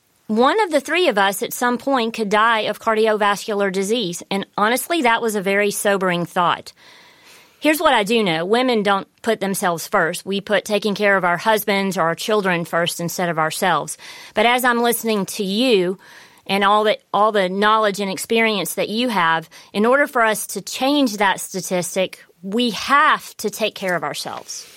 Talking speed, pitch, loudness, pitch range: 190 wpm, 210 Hz, -18 LUFS, 190-230 Hz